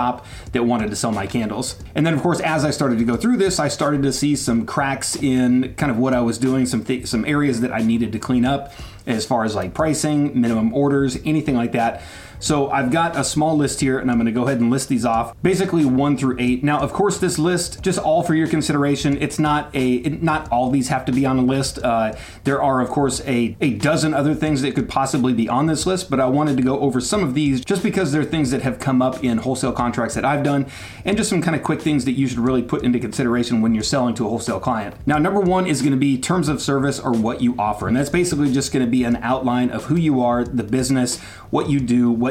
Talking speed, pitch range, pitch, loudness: 265 wpm, 120-150 Hz, 135 Hz, -19 LUFS